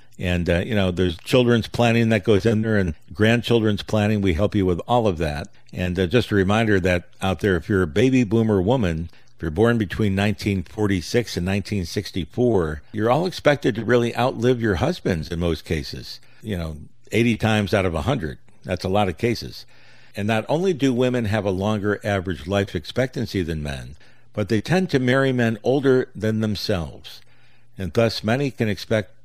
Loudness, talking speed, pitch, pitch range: -21 LUFS, 190 wpm, 105 Hz, 95-120 Hz